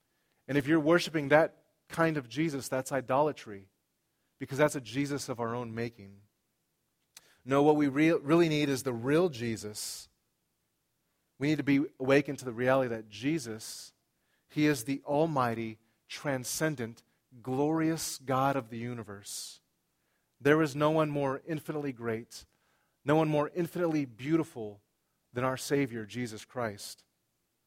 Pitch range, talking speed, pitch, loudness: 120-150 Hz, 140 wpm, 140 Hz, -31 LUFS